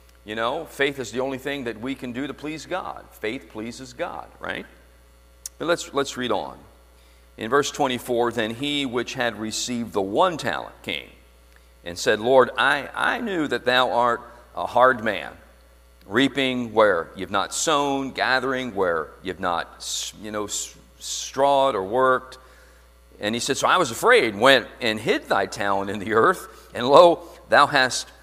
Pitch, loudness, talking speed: 120 Hz, -22 LUFS, 170 wpm